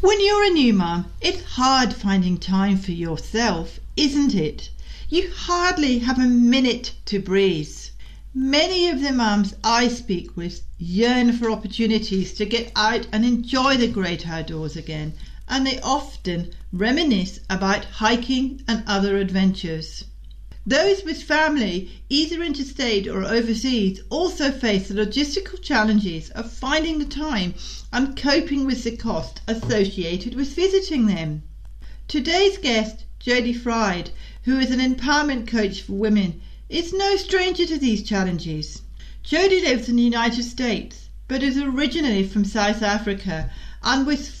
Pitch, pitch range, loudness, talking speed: 235 Hz, 195-275 Hz, -21 LUFS, 140 wpm